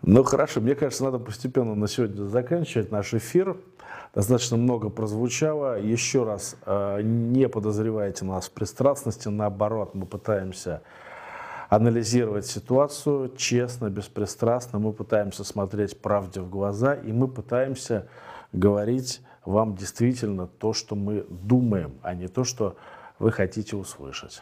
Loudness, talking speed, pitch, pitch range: -26 LUFS, 125 wpm, 110 Hz, 100-125 Hz